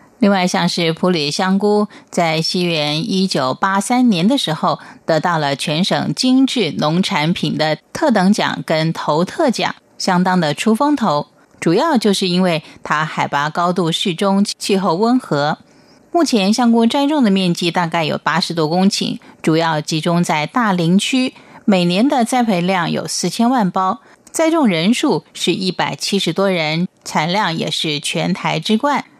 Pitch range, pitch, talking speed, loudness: 165-230 Hz, 185 Hz, 235 characters per minute, -16 LUFS